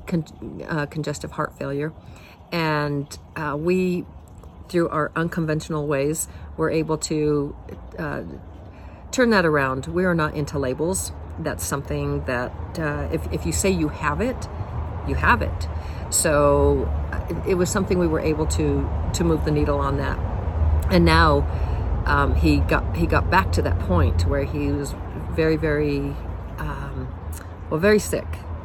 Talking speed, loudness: 155 wpm, -23 LUFS